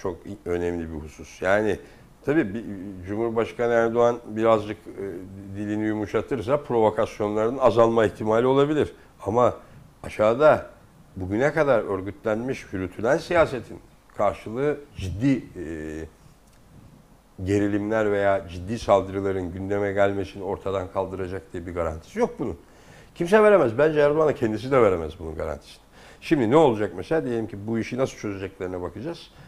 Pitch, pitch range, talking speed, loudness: 105 Hz, 95-120 Hz, 120 wpm, -24 LUFS